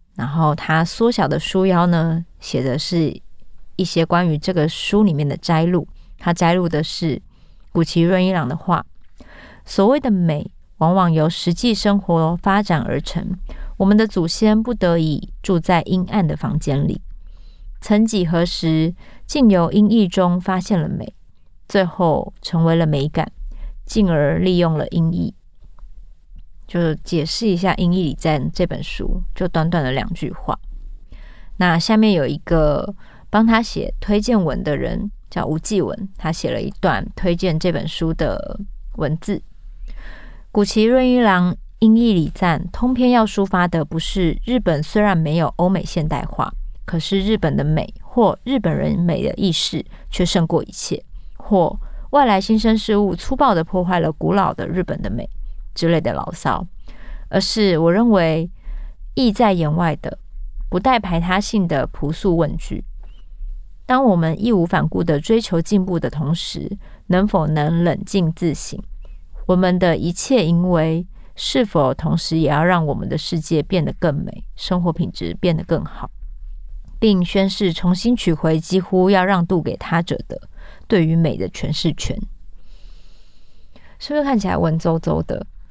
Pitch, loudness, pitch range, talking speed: 175 Hz, -18 LUFS, 160-195 Hz, 225 characters per minute